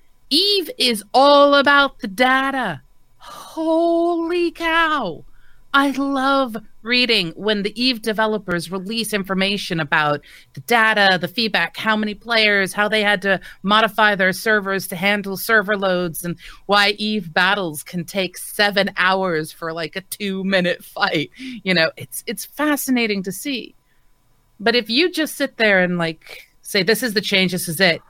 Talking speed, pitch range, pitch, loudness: 155 wpm, 190-250 Hz, 210 Hz, -18 LUFS